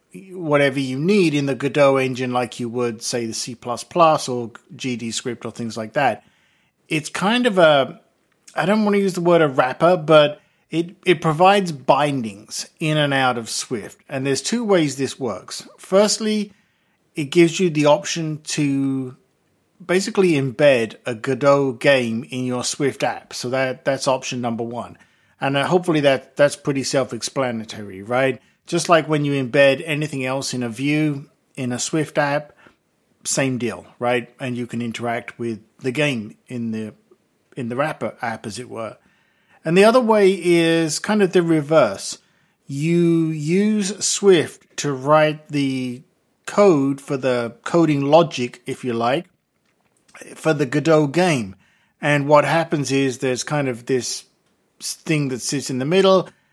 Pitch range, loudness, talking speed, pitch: 125-165 Hz, -19 LUFS, 160 wpm, 145 Hz